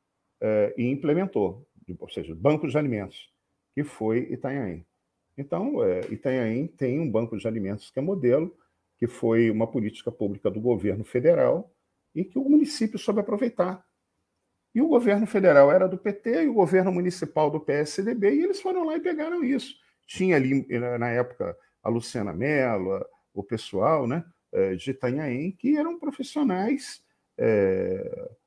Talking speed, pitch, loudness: 150 wpm, 165 Hz, -25 LUFS